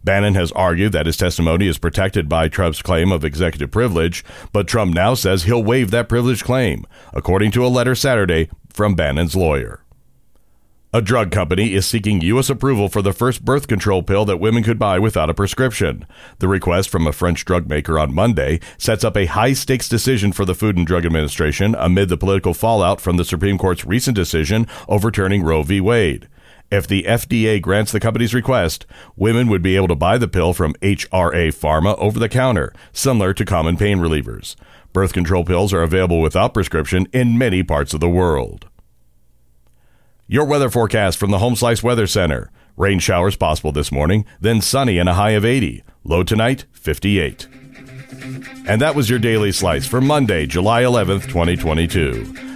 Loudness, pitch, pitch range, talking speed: -17 LUFS, 100 Hz, 85-115 Hz, 185 wpm